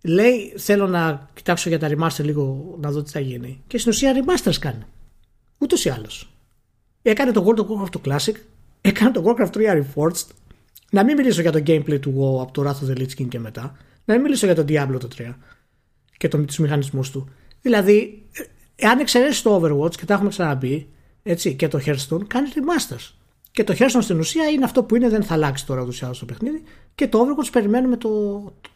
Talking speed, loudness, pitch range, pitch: 210 wpm, -20 LUFS, 145-230 Hz, 175 Hz